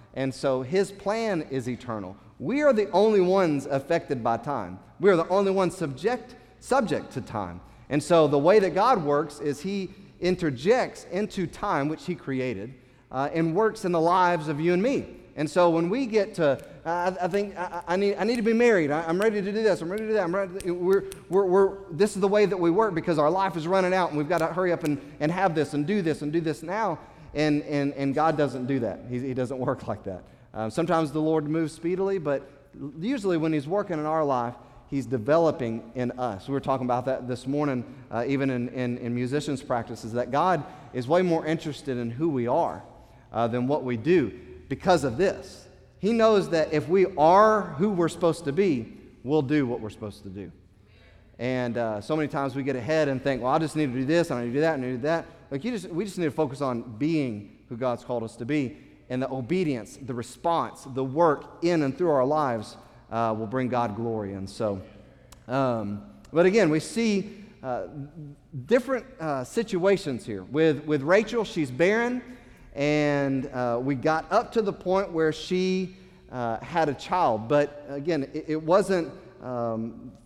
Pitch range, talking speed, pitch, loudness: 125-180 Hz, 215 wpm, 150 Hz, -26 LUFS